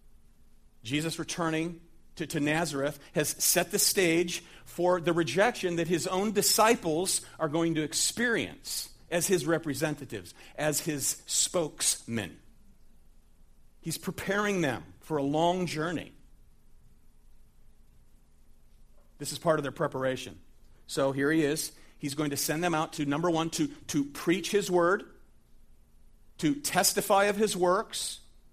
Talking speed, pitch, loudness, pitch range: 130 wpm, 160 Hz, -29 LUFS, 145-175 Hz